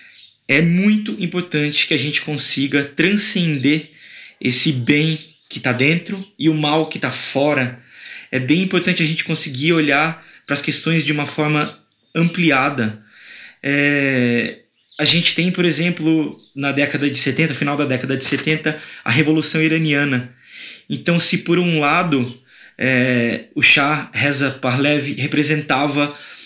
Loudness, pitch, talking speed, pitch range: -17 LUFS, 150 Hz, 135 wpm, 140-160 Hz